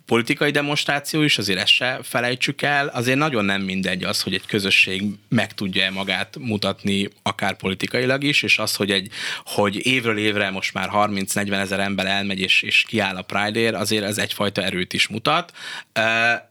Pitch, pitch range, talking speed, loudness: 105 Hz, 100-120 Hz, 175 wpm, -20 LUFS